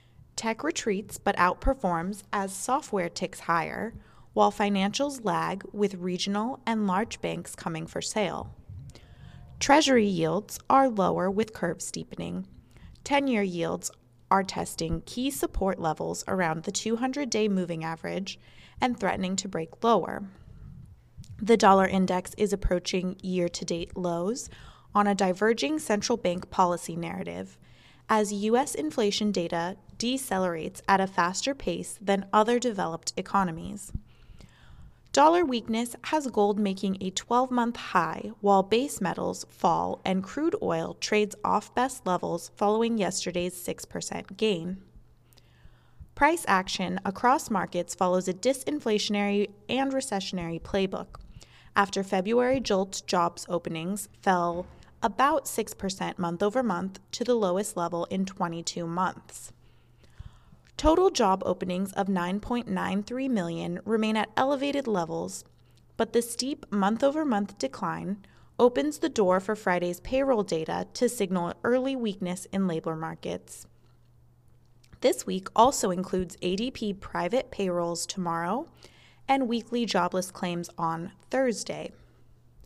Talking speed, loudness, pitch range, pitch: 120 wpm, -28 LUFS, 175-230 Hz, 195 Hz